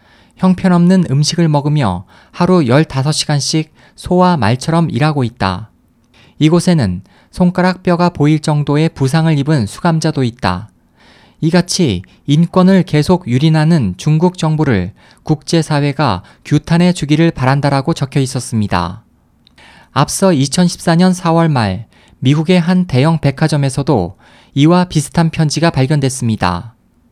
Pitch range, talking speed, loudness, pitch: 125-170 Hz, 270 characters per minute, -13 LUFS, 150 Hz